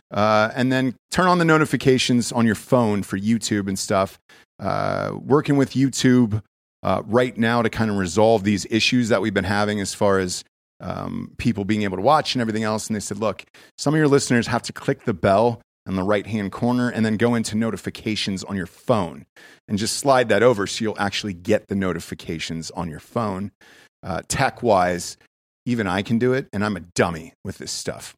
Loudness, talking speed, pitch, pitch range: -21 LUFS, 210 wpm, 110 Hz, 100-120 Hz